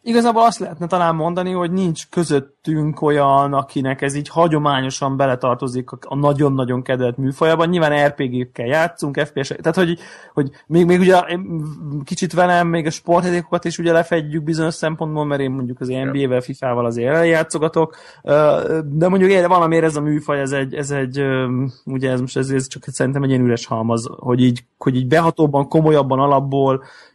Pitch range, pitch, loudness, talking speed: 135-165 Hz, 145 Hz, -18 LUFS, 165 wpm